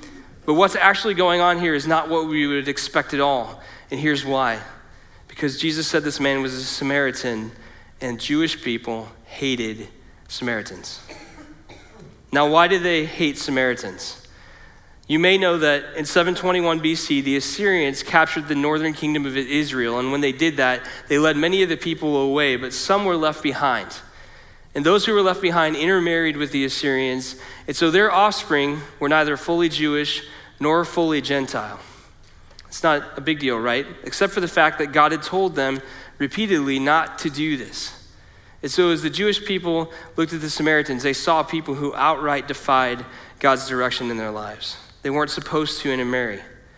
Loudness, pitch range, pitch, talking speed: -20 LUFS, 130-160 Hz, 145 Hz, 175 wpm